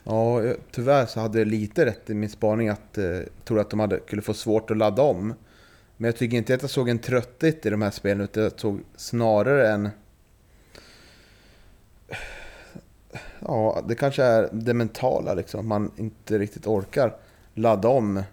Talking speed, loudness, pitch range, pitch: 175 wpm, -24 LUFS, 105-115 Hz, 110 Hz